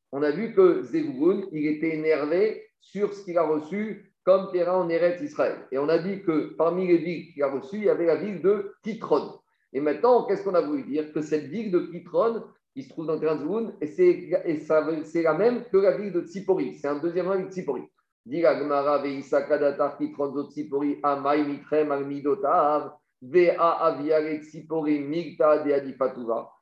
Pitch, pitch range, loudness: 165 Hz, 150-195 Hz, -25 LUFS